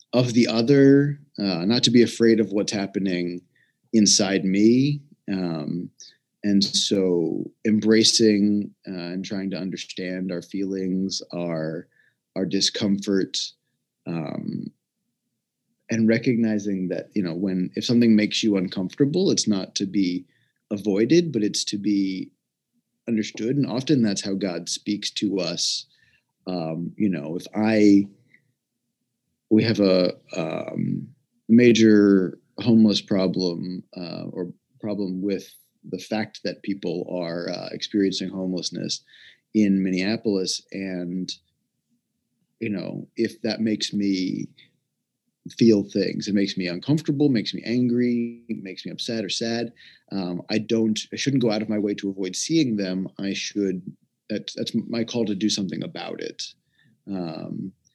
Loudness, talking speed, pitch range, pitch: -23 LUFS, 135 wpm, 95-110 Hz, 100 Hz